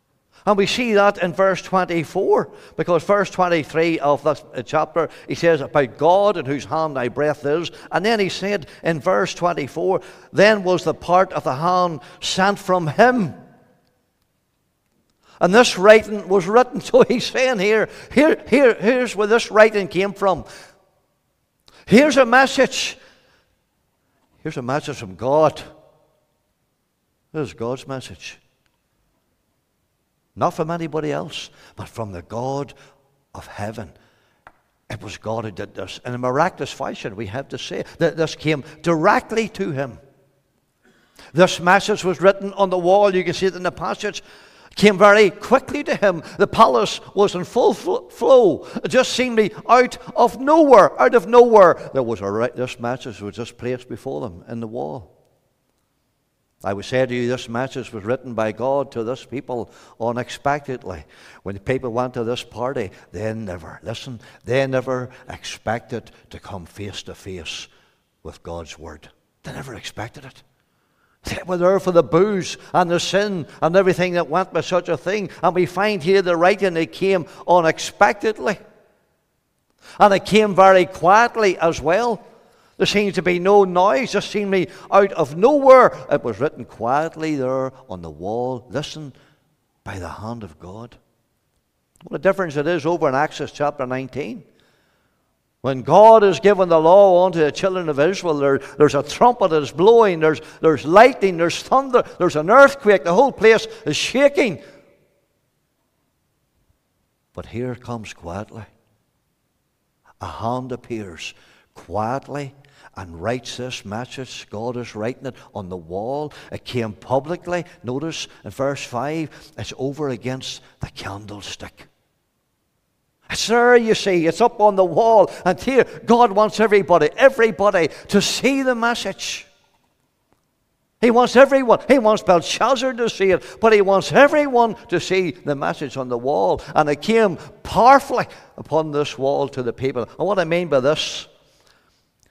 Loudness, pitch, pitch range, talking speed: -18 LUFS, 160 Hz, 125-200 Hz, 160 wpm